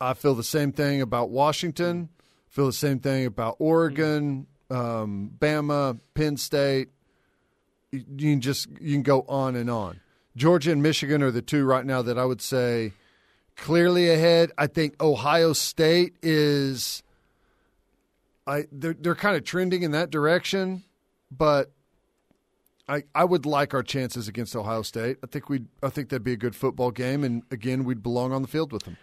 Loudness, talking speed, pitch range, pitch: -25 LUFS, 175 wpm, 125-155 Hz, 140 Hz